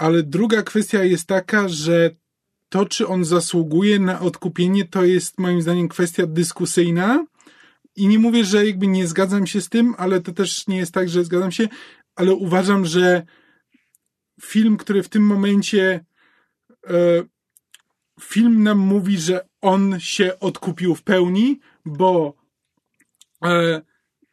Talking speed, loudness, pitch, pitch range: 135 wpm, -18 LUFS, 185 Hz, 175-205 Hz